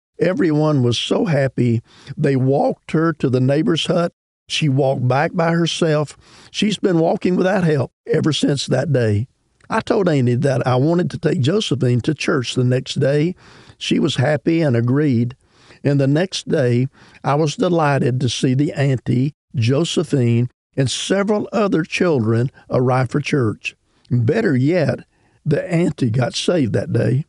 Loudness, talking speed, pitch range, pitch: -18 LUFS, 155 wpm, 125-160 Hz, 140 Hz